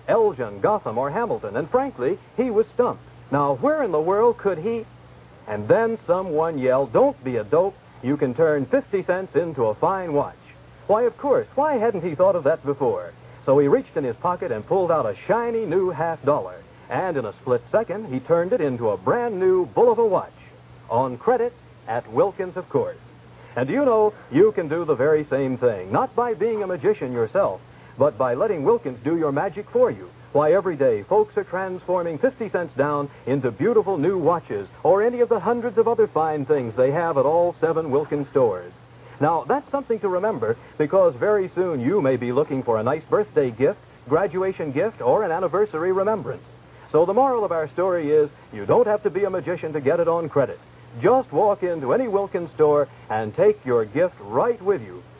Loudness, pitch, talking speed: -22 LUFS, 205 Hz, 205 wpm